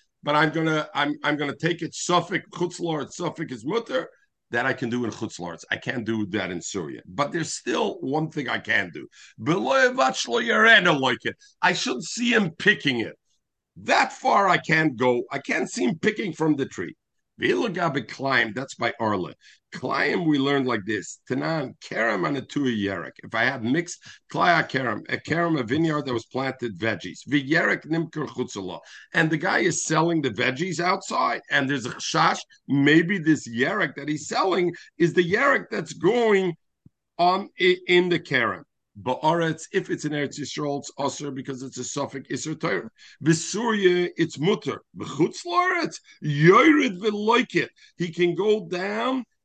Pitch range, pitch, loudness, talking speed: 135-180 Hz, 160 Hz, -24 LUFS, 155 wpm